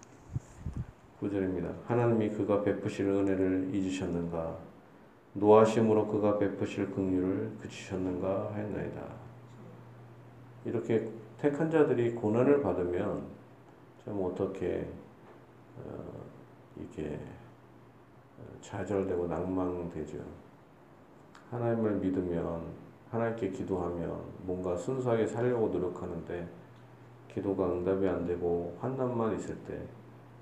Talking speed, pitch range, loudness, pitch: 235 characters per minute, 90-115 Hz, -32 LUFS, 100 Hz